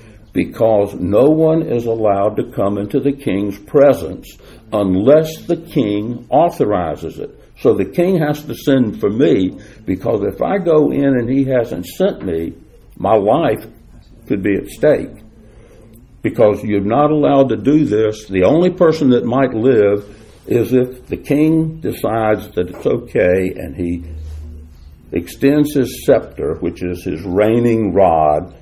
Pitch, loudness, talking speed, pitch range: 115 Hz, -15 LUFS, 150 wpm, 100-140 Hz